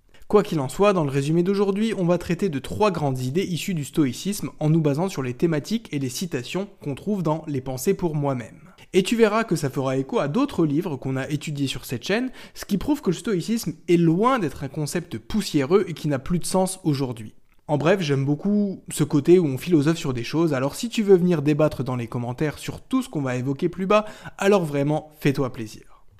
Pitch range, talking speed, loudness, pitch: 140-195 Hz, 235 wpm, -23 LUFS, 160 Hz